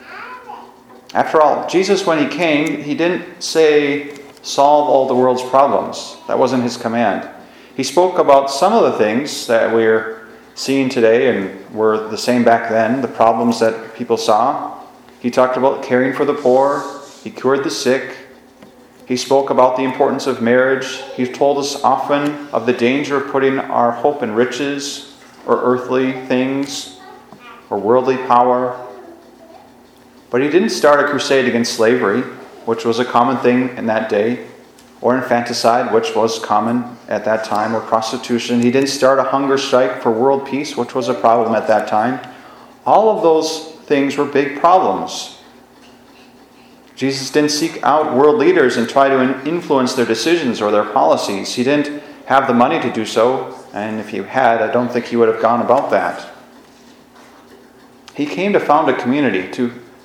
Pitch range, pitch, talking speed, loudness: 120-140 Hz, 130 Hz, 170 wpm, -15 LUFS